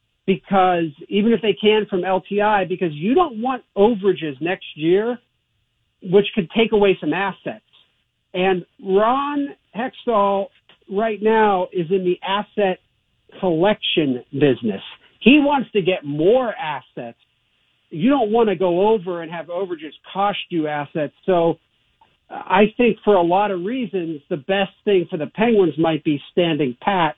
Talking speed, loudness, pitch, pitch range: 150 wpm, -19 LUFS, 190 Hz, 170-210 Hz